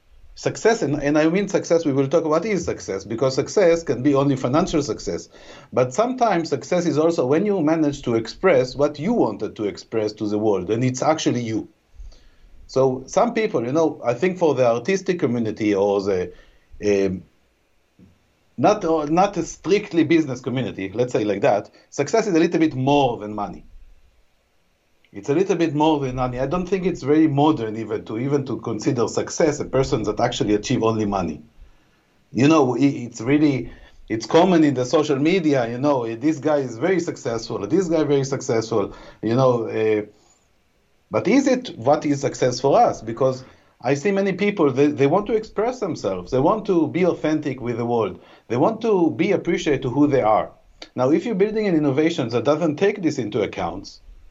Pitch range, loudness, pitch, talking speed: 110-160 Hz, -21 LUFS, 140 Hz, 190 wpm